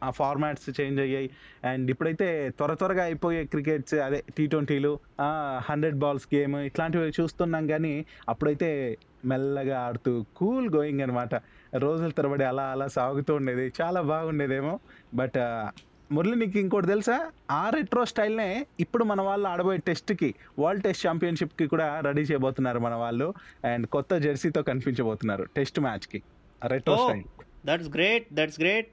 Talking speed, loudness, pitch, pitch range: 135 wpm, -28 LUFS, 150 Hz, 135-170 Hz